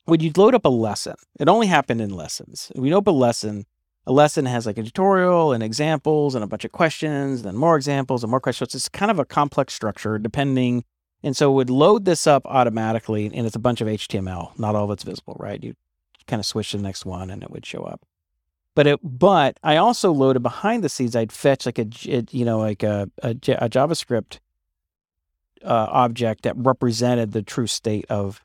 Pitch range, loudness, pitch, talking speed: 105-145 Hz, -20 LUFS, 120 Hz, 220 wpm